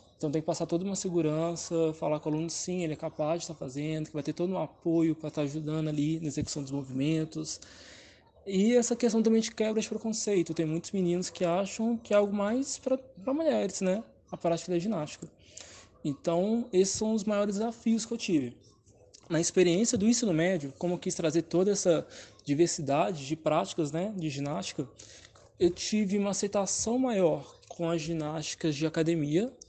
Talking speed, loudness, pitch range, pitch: 190 wpm, -30 LUFS, 155-205 Hz, 170 Hz